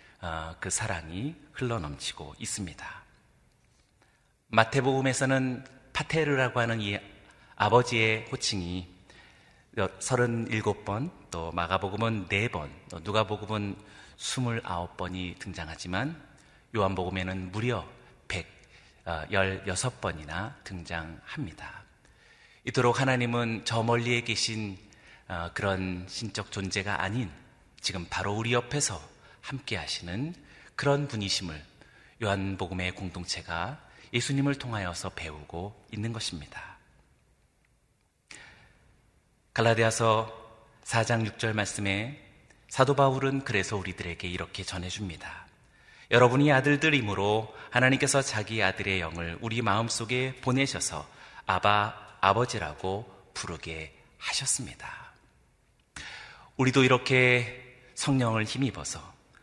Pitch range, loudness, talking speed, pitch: 95-125 Hz, -29 LUFS, 235 characters per minute, 105 Hz